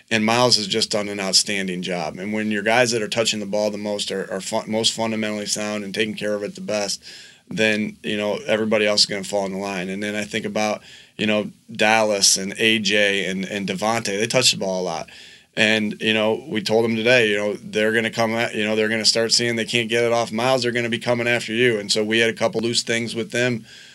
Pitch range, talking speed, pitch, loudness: 105-115 Hz, 270 wpm, 110 Hz, -20 LUFS